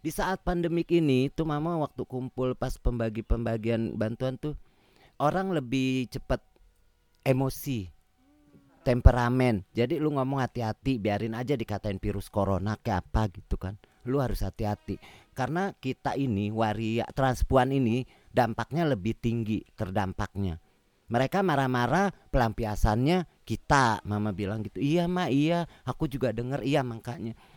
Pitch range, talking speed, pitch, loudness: 105-140 Hz, 125 wpm, 120 Hz, -29 LUFS